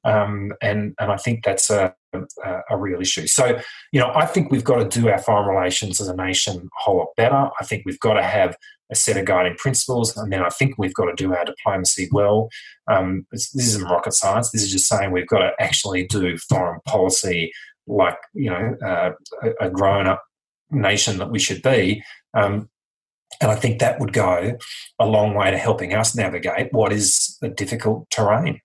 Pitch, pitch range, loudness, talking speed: 105 Hz, 95-120 Hz, -20 LUFS, 205 wpm